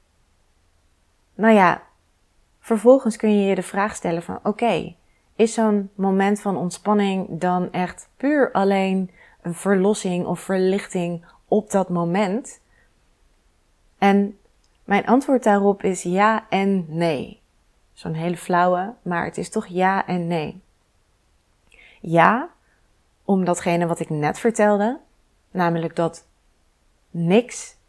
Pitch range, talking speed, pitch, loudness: 165-205 Hz, 120 wpm, 185 Hz, -21 LUFS